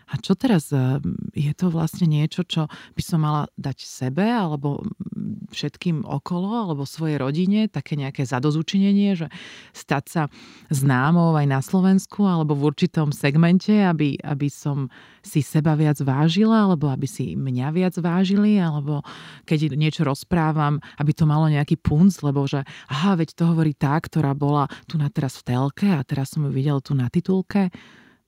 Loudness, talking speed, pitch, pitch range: -22 LUFS, 165 wpm, 155 Hz, 145-185 Hz